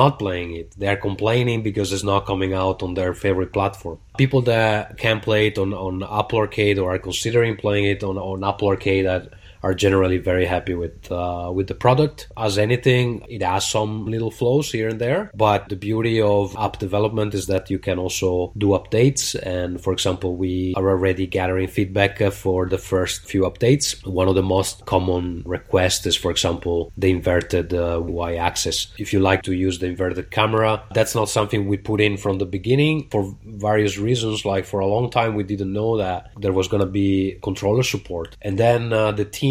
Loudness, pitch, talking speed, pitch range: -21 LUFS, 100 Hz, 200 wpm, 95-110 Hz